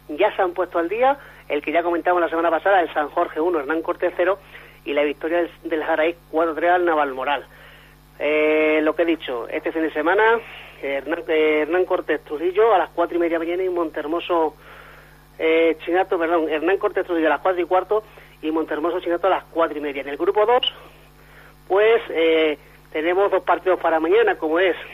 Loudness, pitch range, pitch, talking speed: -21 LUFS, 155-180 Hz, 170 Hz, 200 wpm